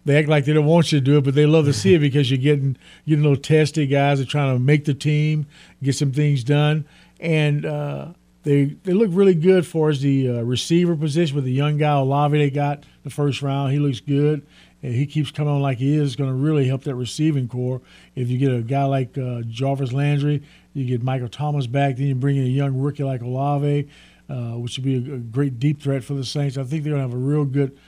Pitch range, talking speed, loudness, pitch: 135-150 Hz, 255 wpm, -20 LUFS, 140 Hz